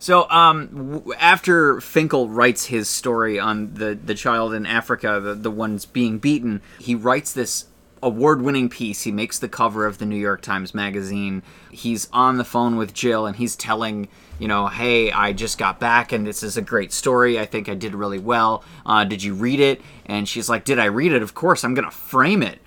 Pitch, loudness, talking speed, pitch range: 110 Hz, -20 LUFS, 215 wpm, 105-120 Hz